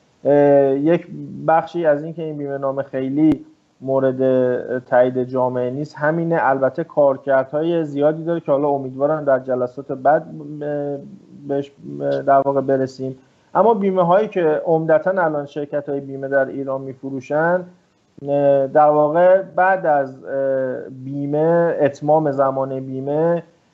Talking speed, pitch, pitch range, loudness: 120 wpm, 140 Hz, 135-160 Hz, -18 LUFS